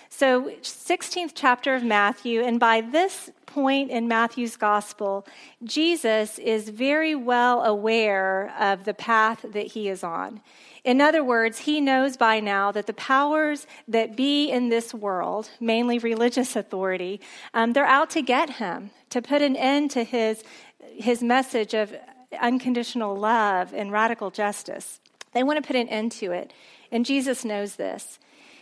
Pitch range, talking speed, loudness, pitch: 215-270 Hz, 155 wpm, -24 LUFS, 235 Hz